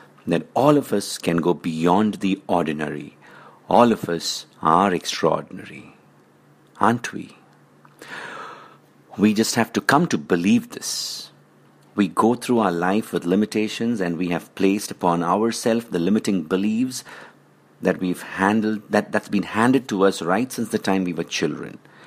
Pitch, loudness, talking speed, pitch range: 100 Hz, -21 LUFS, 150 wpm, 90-110 Hz